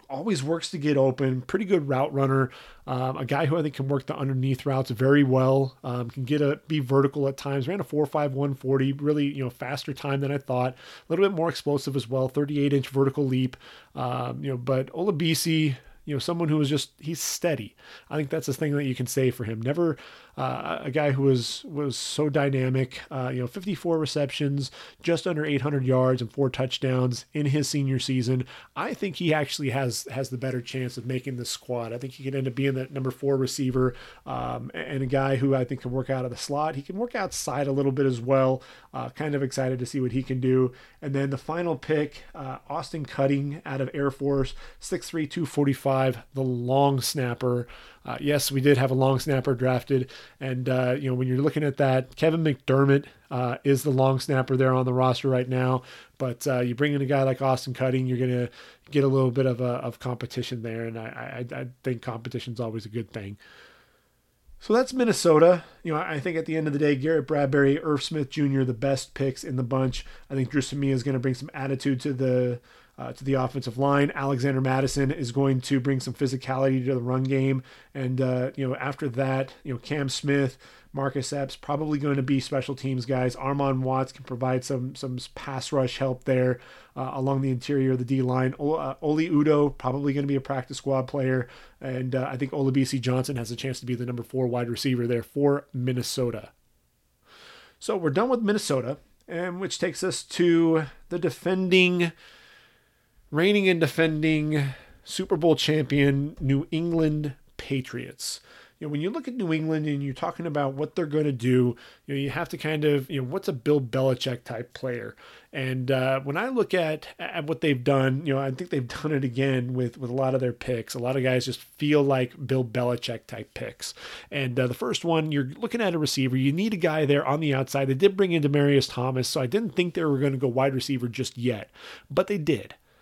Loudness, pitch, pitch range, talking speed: -26 LUFS, 135 Hz, 130-150 Hz, 220 wpm